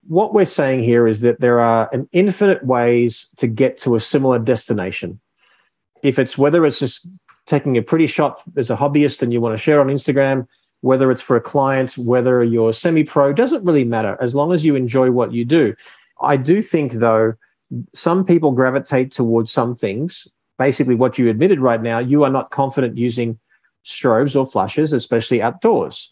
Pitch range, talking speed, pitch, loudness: 120-145 Hz, 185 wpm, 130 Hz, -16 LUFS